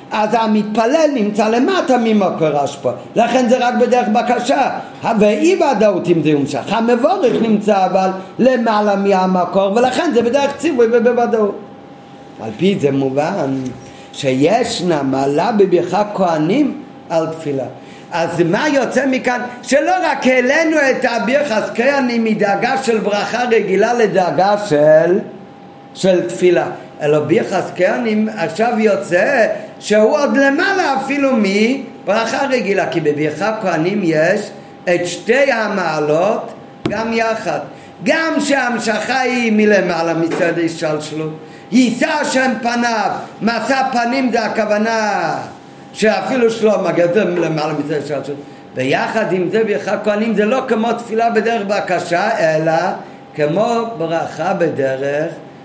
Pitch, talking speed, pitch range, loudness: 210 Hz, 120 wpm, 170-245 Hz, -15 LUFS